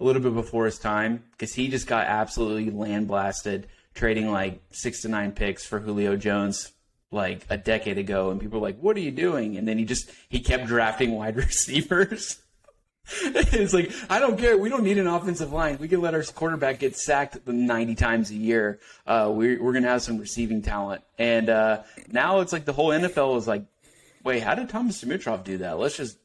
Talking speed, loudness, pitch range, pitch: 215 wpm, -25 LUFS, 105-155 Hz, 115 Hz